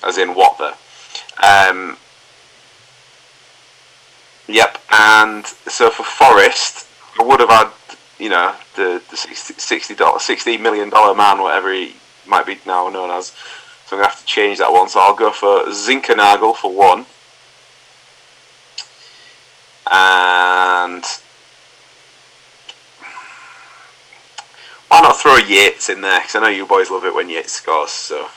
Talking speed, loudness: 135 wpm, -12 LUFS